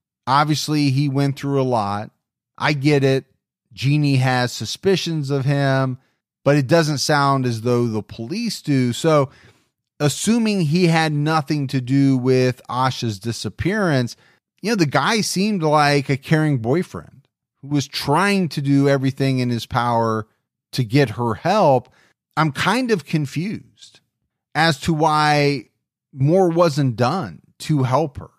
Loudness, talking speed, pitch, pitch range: -19 LUFS, 145 wpm, 140 Hz, 125-155 Hz